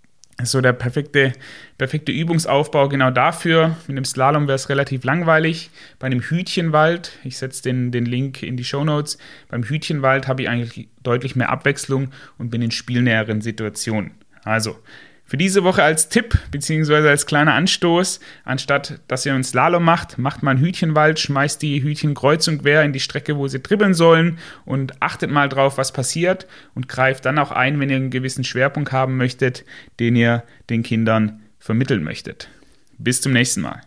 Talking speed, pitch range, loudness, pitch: 175 wpm, 125-150 Hz, -18 LUFS, 135 Hz